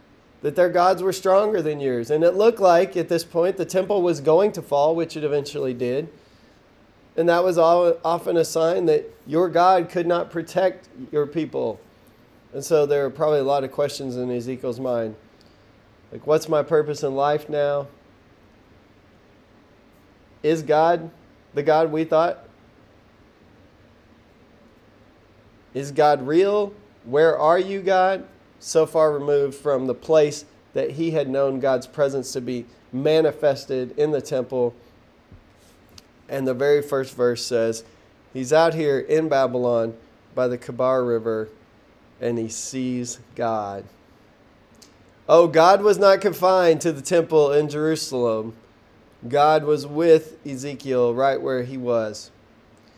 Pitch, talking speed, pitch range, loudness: 140 Hz, 145 wpm, 120-160 Hz, -21 LUFS